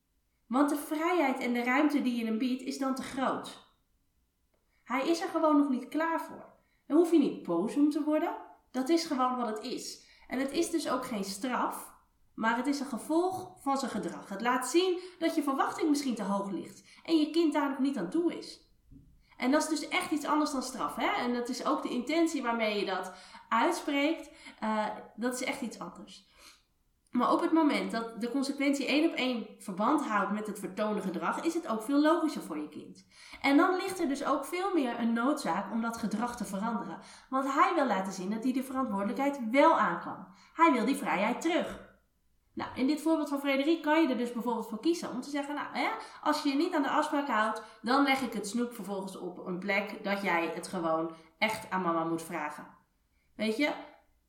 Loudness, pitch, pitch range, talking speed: -31 LUFS, 265 Hz, 220-305 Hz, 220 wpm